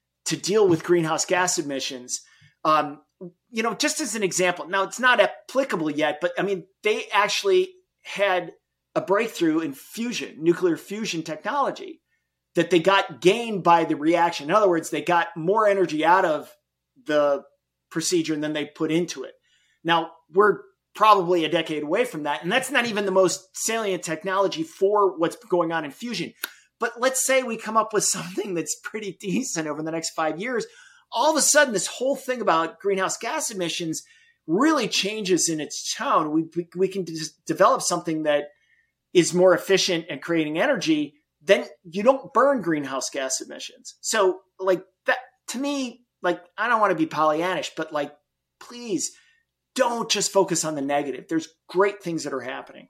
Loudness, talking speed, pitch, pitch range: -23 LUFS, 175 wpm, 185 Hz, 160-225 Hz